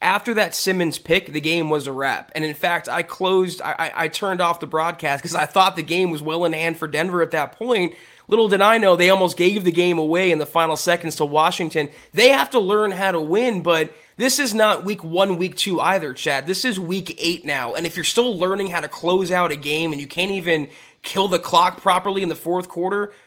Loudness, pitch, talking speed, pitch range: -20 LUFS, 175 Hz, 245 wpm, 160-190 Hz